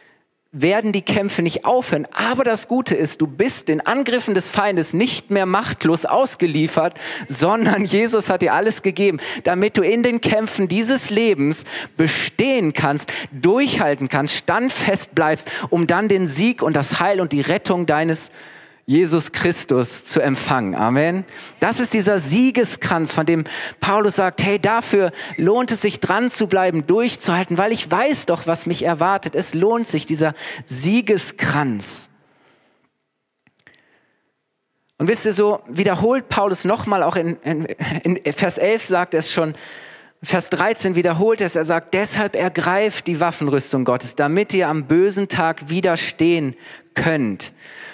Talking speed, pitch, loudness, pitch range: 145 wpm, 180 Hz, -19 LUFS, 160-210 Hz